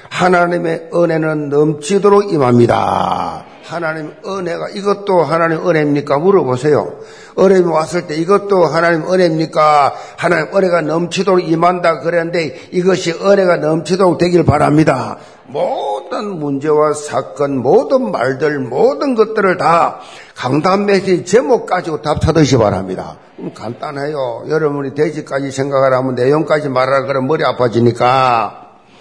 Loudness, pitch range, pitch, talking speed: -14 LUFS, 145-180 Hz, 165 Hz, 325 characters per minute